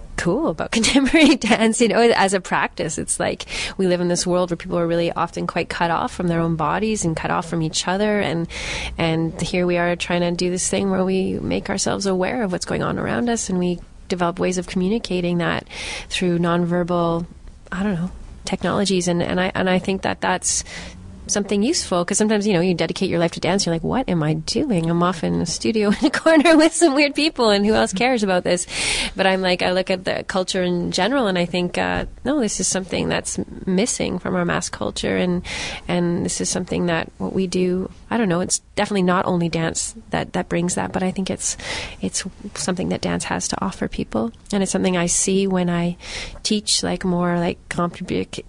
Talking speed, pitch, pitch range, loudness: 225 wpm, 185 Hz, 175-205 Hz, -20 LUFS